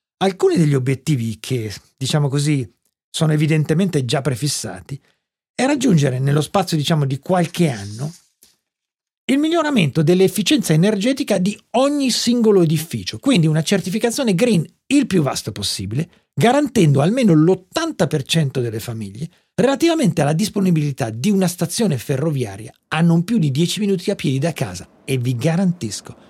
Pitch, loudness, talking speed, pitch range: 165 Hz, -18 LUFS, 135 wpm, 140-200 Hz